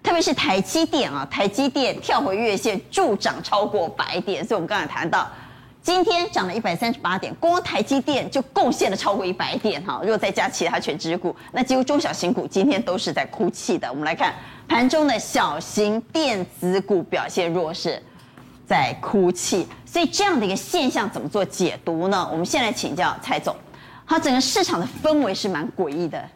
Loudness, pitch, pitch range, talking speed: -22 LUFS, 260 Hz, 195-315 Hz, 300 characters per minute